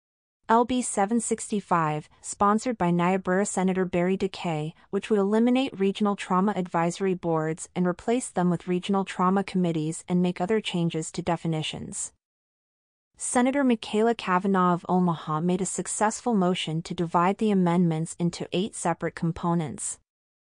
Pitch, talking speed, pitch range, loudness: 180 Hz, 130 wpm, 170-205 Hz, -26 LUFS